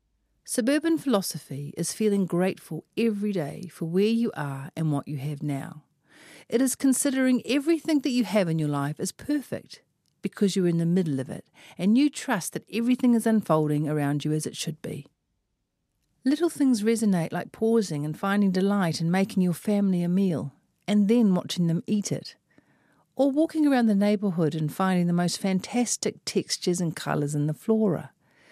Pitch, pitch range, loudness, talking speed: 190 Hz, 160-230 Hz, -26 LUFS, 180 wpm